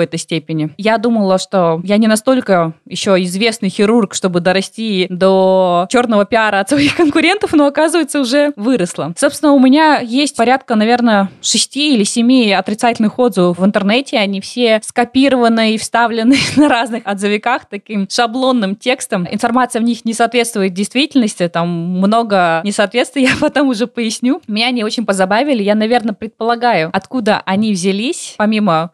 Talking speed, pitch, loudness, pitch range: 150 wpm, 225 Hz, -13 LUFS, 195-255 Hz